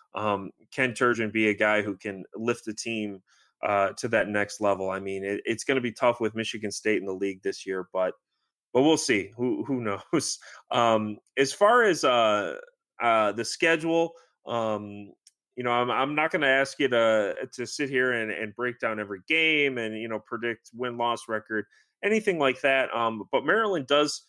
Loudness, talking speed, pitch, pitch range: -26 LUFS, 195 wpm, 115 Hz, 105-135 Hz